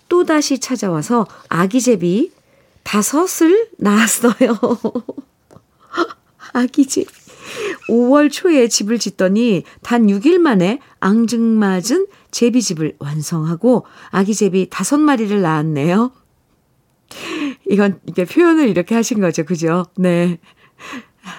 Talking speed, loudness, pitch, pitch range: 210 characters per minute, -16 LUFS, 230 Hz, 185-275 Hz